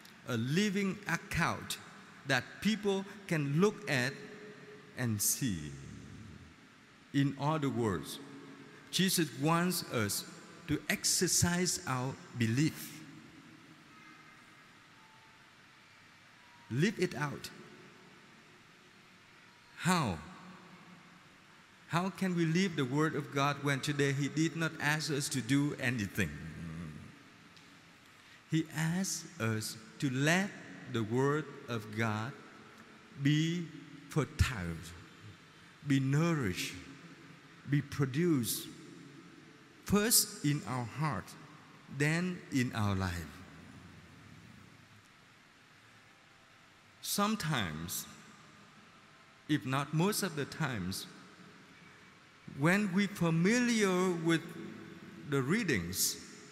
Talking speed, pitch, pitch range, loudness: 85 wpm, 150 Hz, 130-175 Hz, -33 LUFS